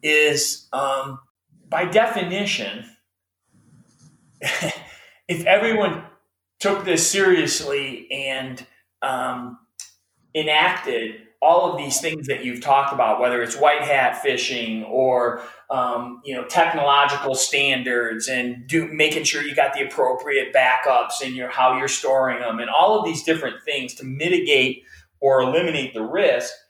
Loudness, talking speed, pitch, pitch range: -20 LUFS, 130 wpm, 135 Hz, 125-160 Hz